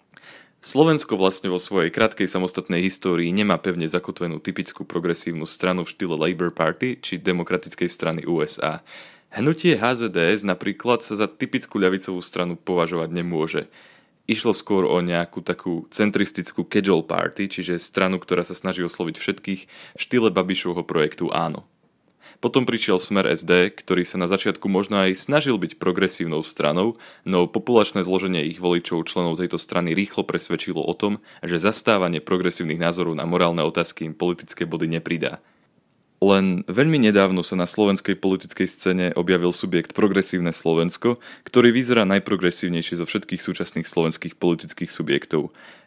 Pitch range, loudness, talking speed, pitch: 85-100 Hz, -22 LUFS, 145 wpm, 90 Hz